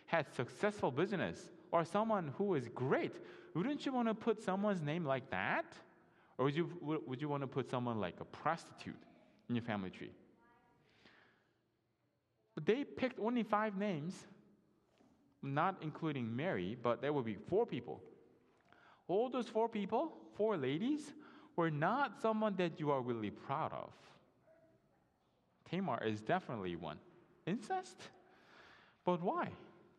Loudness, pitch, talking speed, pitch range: -39 LUFS, 170 Hz, 140 wpm, 130-210 Hz